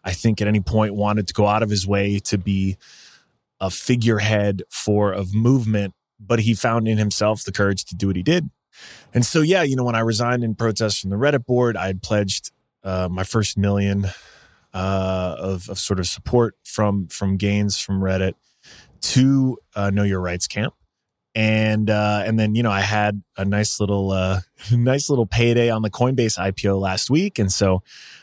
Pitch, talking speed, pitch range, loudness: 105 Hz, 195 wpm, 95-115 Hz, -20 LUFS